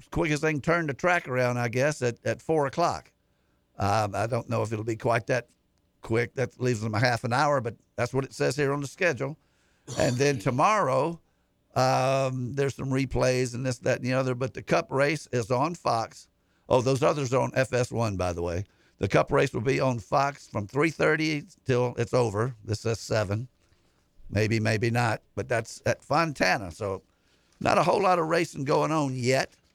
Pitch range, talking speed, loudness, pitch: 115-140 Hz, 205 wpm, -27 LUFS, 125 Hz